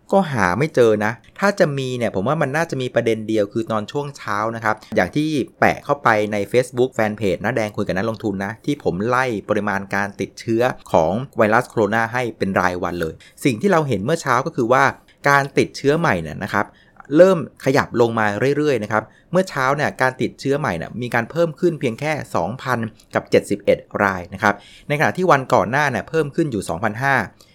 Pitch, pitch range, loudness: 120 Hz, 105-145 Hz, -19 LUFS